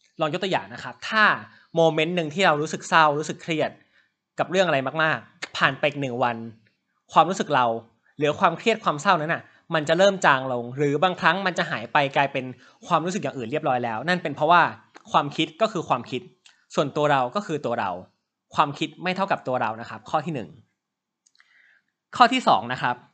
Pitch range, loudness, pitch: 135-180 Hz, -23 LUFS, 155 Hz